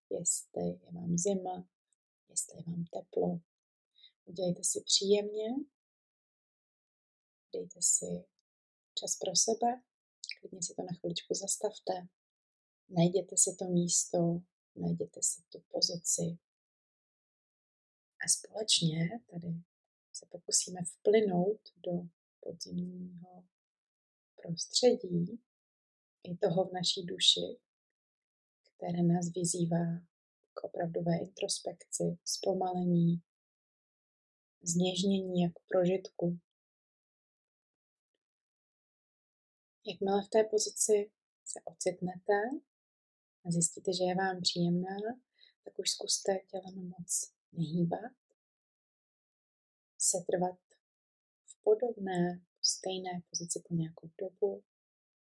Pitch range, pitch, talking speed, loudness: 170-195 Hz, 180 Hz, 90 wpm, -33 LUFS